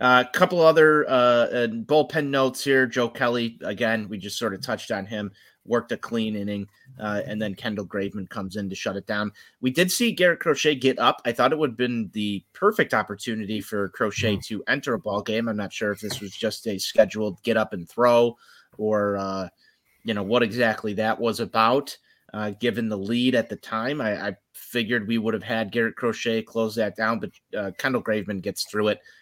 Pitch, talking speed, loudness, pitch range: 110 Hz, 215 wpm, -24 LUFS, 105-125 Hz